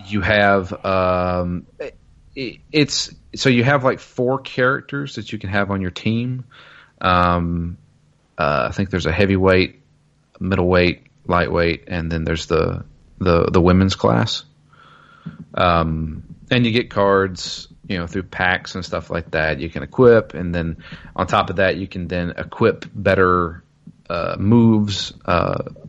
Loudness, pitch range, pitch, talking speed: -19 LUFS, 85-110 Hz, 95 Hz, 150 wpm